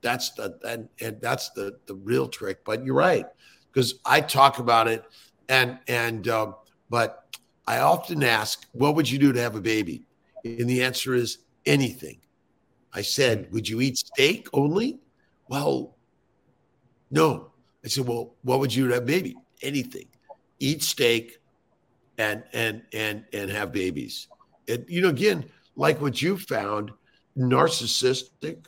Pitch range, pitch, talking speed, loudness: 115-140 Hz, 125 Hz, 155 wpm, -25 LUFS